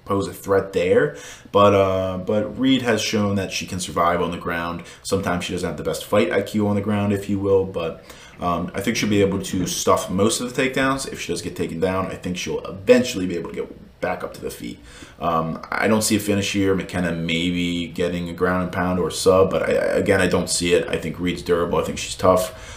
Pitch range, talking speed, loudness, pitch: 90-100 Hz, 250 wpm, -21 LUFS, 95 Hz